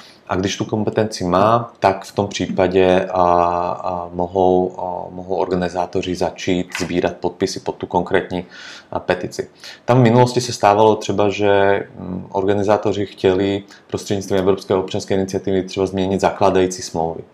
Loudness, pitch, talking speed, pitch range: -18 LUFS, 95 Hz, 140 wpm, 90-100 Hz